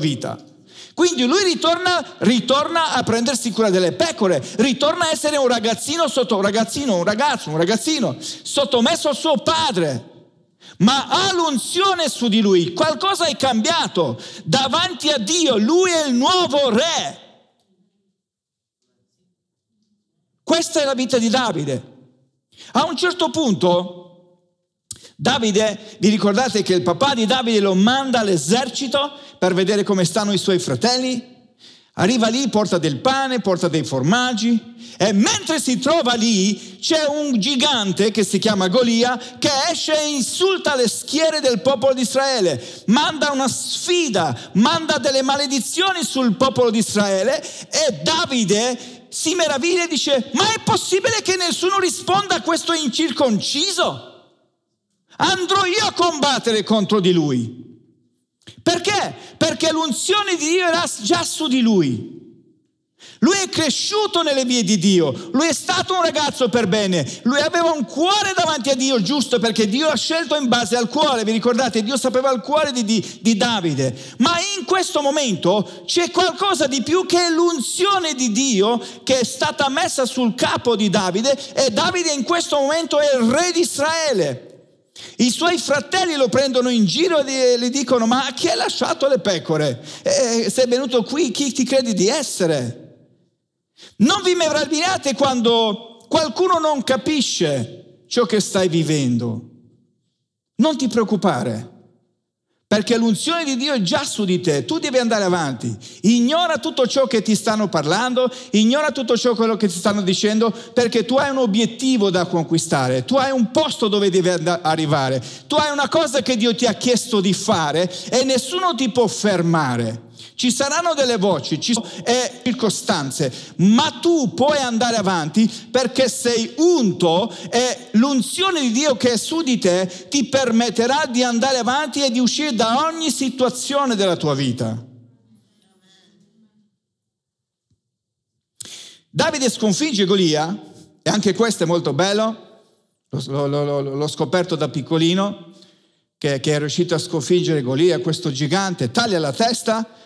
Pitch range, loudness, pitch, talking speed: 195-295 Hz, -18 LUFS, 245 Hz, 150 wpm